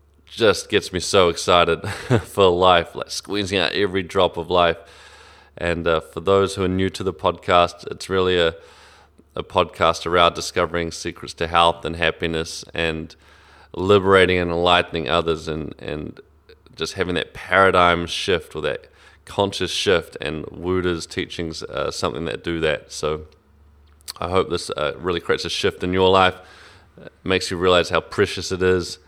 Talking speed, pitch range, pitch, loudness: 165 wpm, 80-95 Hz, 85 Hz, -20 LUFS